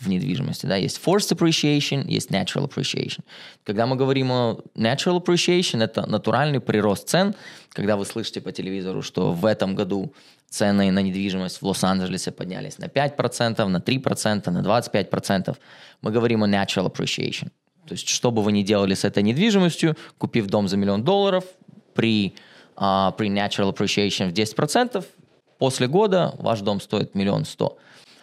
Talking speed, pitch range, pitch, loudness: 165 wpm, 100-160 Hz, 115 Hz, -22 LUFS